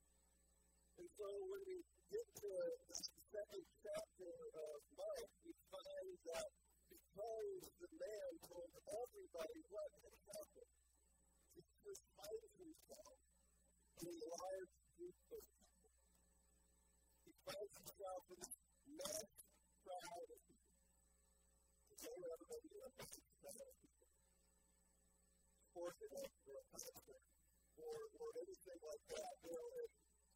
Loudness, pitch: -55 LUFS, 200 Hz